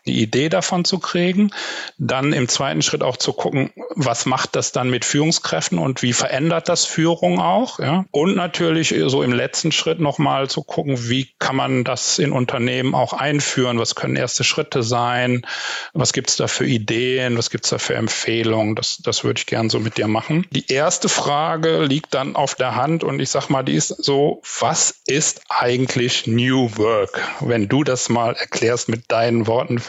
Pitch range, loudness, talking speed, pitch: 120-160 Hz, -19 LUFS, 190 wpm, 135 Hz